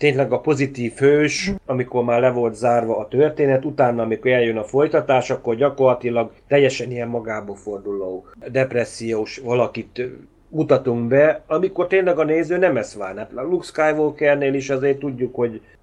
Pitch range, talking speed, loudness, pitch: 120-145 Hz, 155 wpm, -20 LUFS, 130 Hz